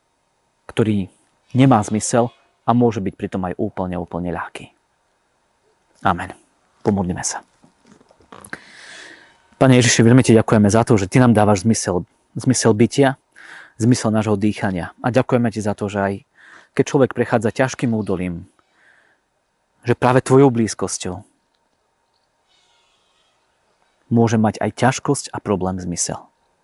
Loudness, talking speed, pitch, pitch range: -18 LUFS, 120 wpm, 115 Hz, 100-125 Hz